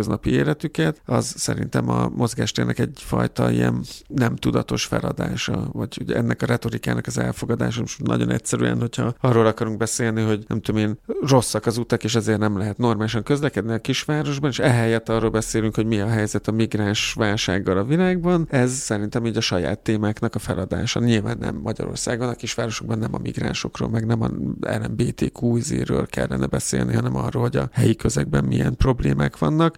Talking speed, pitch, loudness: 170 wpm, 110 Hz, -22 LUFS